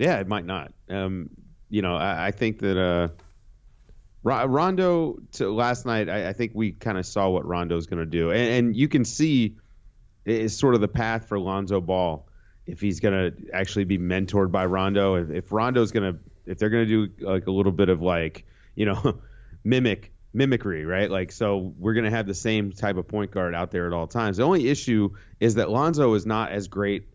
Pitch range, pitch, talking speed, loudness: 95-115 Hz, 100 Hz, 220 wpm, -25 LUFS